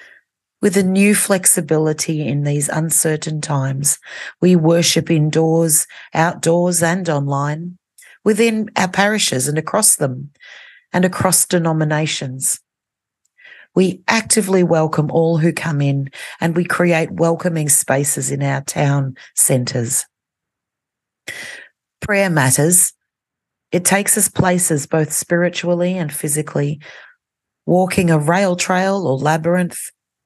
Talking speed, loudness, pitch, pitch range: 110 wpm, -16 LUFS, 165 Hz, 150-185 Hz